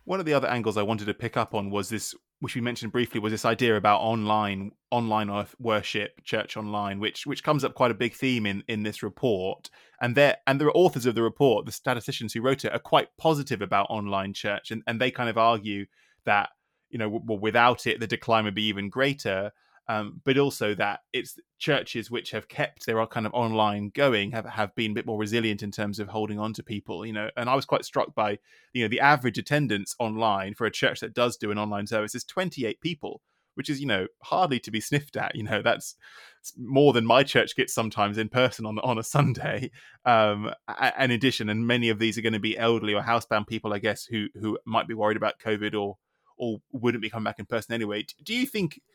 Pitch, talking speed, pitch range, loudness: 115 Hz, 235 wpm, 105-125 Hz, -26 LUFS